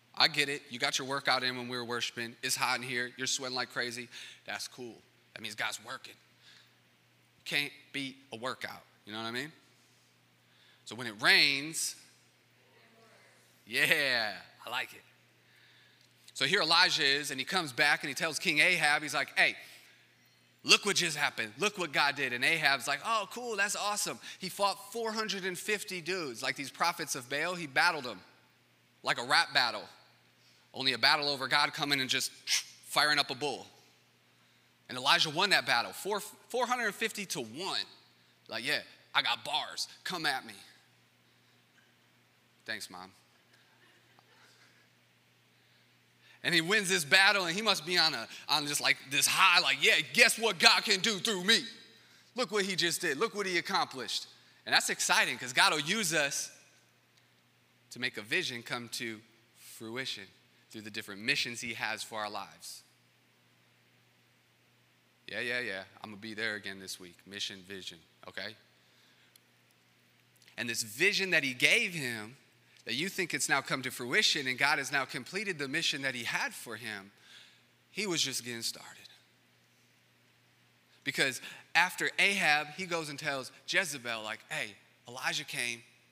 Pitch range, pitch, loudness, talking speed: 115-175 Hz, 140 Hz, -30 LUFS, 165 wpm